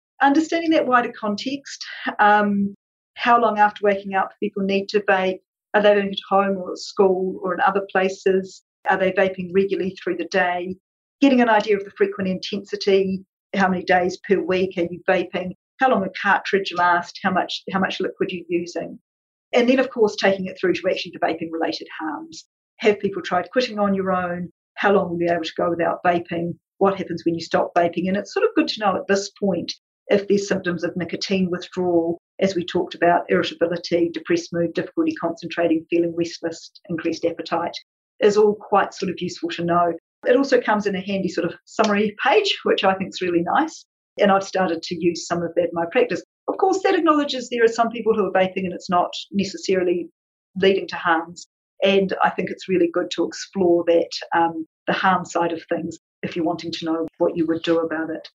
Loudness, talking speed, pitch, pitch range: -21 LUFS, 205 wpm, 185 Hz, 170-200 Hz